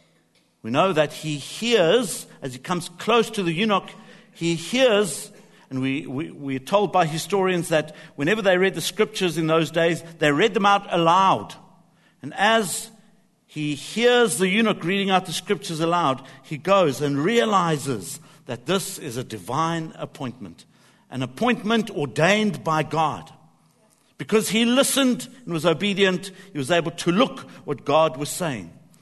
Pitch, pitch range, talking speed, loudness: 175 Hz, 150-205 Hz, 160 wpm, -22 LUFS